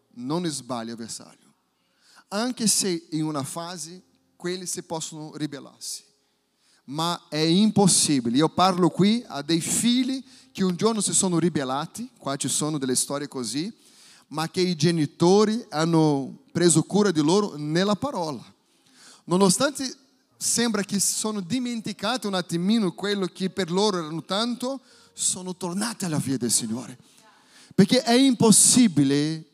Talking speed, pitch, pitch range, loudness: 140 wpm, 185 Hz, 155-215 Hz, -23 LUFS